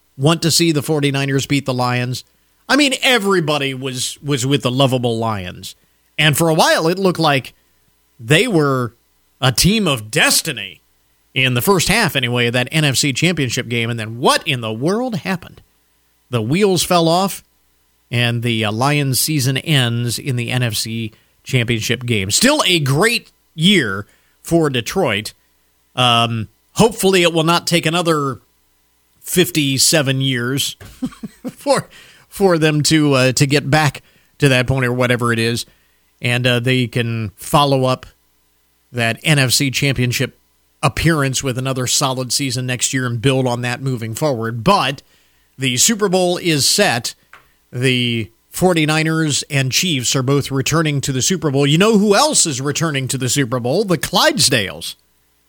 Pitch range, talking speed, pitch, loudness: 120-155 Hz, 155 wpm, 135 Hz, -16 LUFS